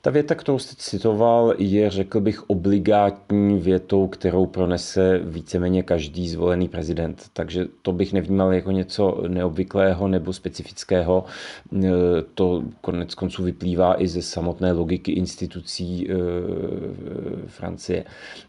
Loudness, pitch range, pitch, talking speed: -22 LUFS, 90-100 Hz, 95 Hz, 115 wpm